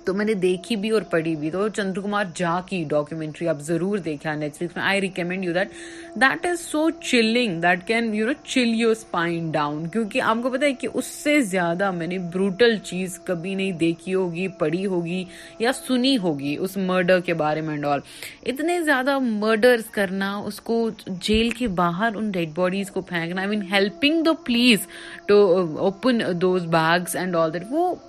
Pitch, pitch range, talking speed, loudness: 195 Hz, 175-230 Hz, 165 wpm, -22 LUFS